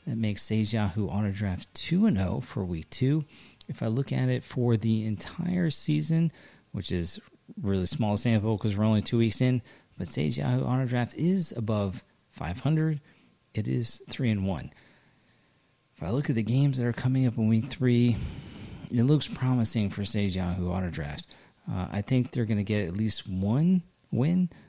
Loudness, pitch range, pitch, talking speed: -28 LUFS, 100-130 Hz, 115 Hz, 180 wpm